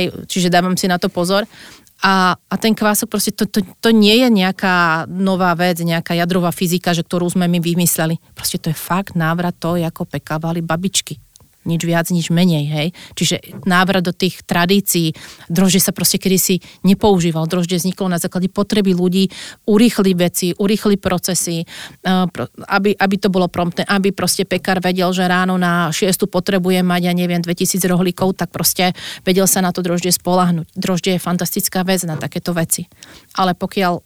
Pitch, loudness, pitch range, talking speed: 180 Hz, -16 LUFS, 175-190 Hz, 175 wpm